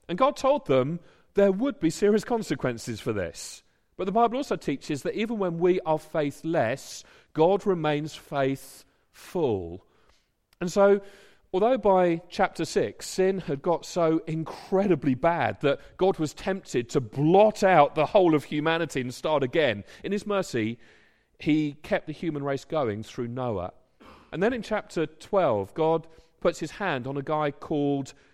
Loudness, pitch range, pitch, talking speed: -26 LUFS, 145-195 Hz, 165 Hz, 160 wpm